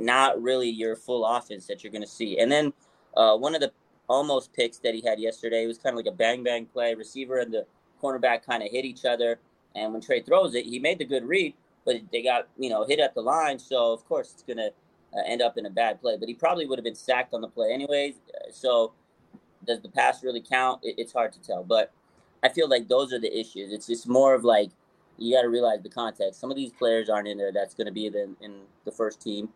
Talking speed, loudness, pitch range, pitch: 250 wpm, -26 LUFS, 110-130 Hz, 120 Hz